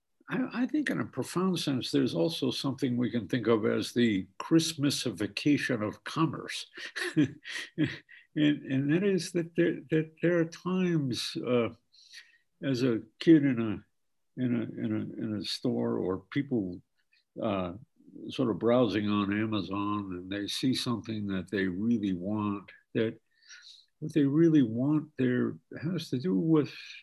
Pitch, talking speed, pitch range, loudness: 125 Hz, 150 wpm, 110-155 Hz, -30 LUFS